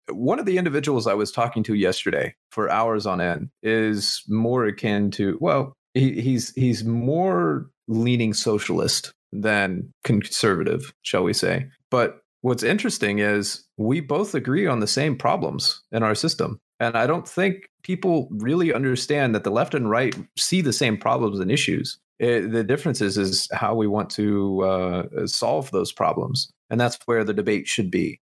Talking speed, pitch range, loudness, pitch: 170 wpm, 105-135 Hz, -23 LUFS, 115 Hz